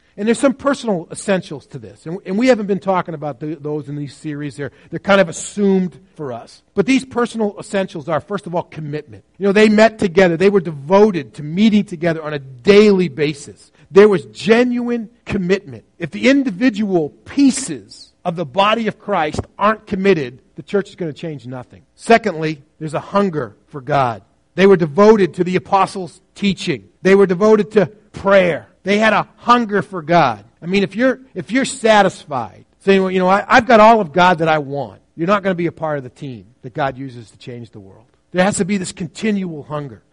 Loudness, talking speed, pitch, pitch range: -16 LUFS, 205 wpm, 185 Hz, 150-205 Hz